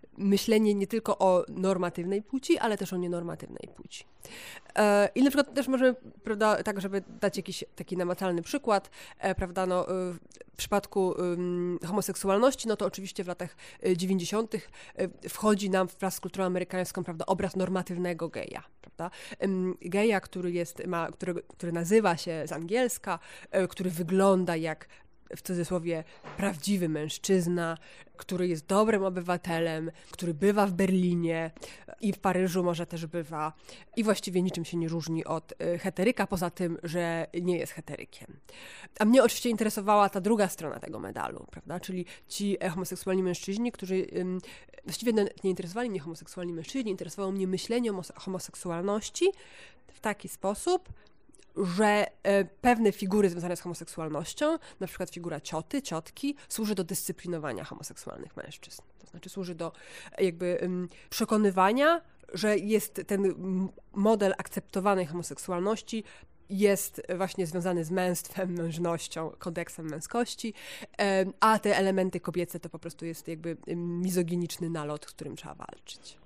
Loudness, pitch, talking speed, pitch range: -30 LUFS, 185 Hz, 135 wpm, 175-205 Hz